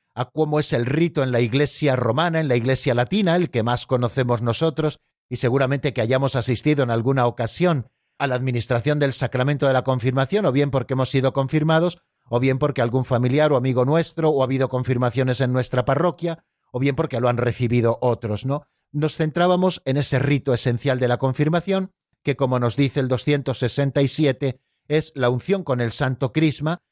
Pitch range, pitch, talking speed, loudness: 125-150 Hz, 135 Hz, 190 wpm, -21 LUFS